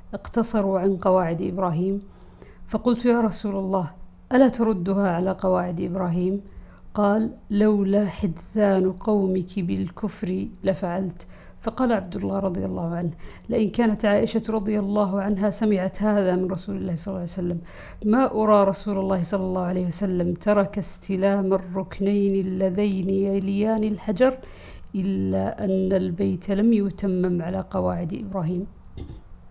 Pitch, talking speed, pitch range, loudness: 195 Hz, 125 wpm, 185-210 Hz, -24 LUFS